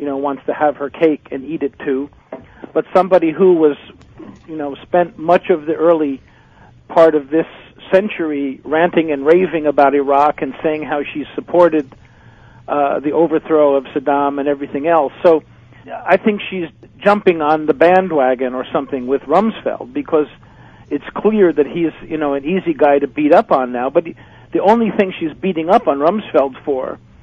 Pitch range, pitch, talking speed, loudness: 140-170 Hz, 155 Hz, 180 wpm, -15 LUFS